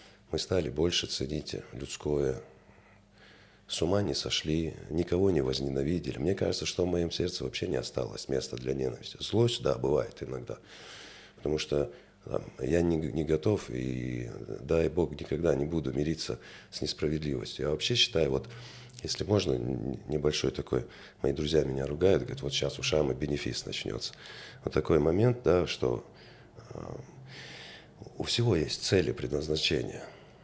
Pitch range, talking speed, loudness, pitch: 70-95 Hz, 145 wpm, -31 LUFS, 80 Hz